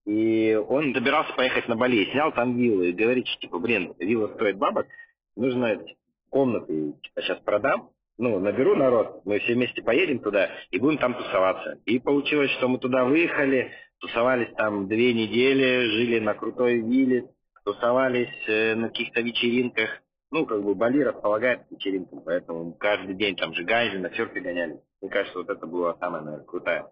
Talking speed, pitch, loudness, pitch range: 165 wpm, 120 Hz, -24 LUFS, 105-125 Hz